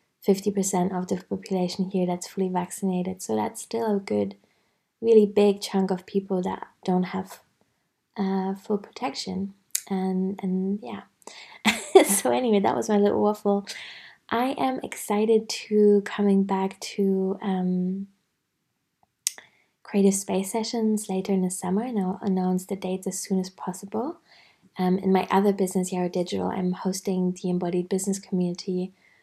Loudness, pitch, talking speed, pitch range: -25 LUFS, 195 Hz, 145 wpm, 185-205 Hz